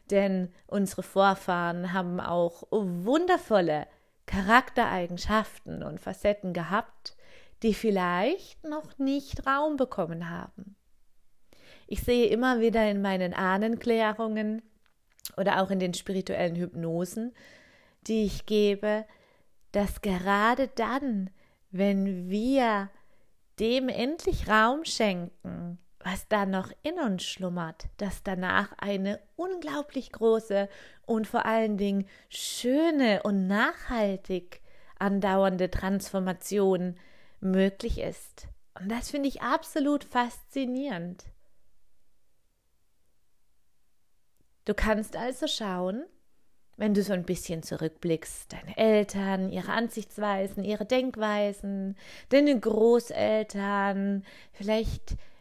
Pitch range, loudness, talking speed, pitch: 190-235 Hz, -28 LUFS, 95 wpm, 205 Hz